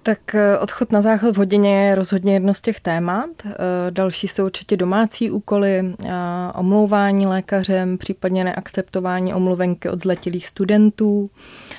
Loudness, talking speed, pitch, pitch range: -19 LUFS, 125 wpm, 195 Hz, 185-205 Hz